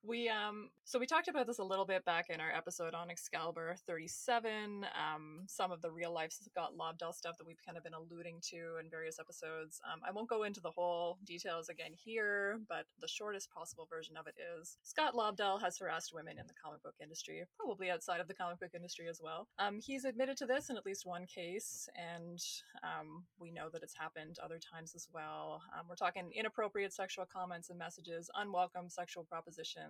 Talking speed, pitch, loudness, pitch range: 210 wpm, 175 Hz, -43 LUFS, 165-205 Hz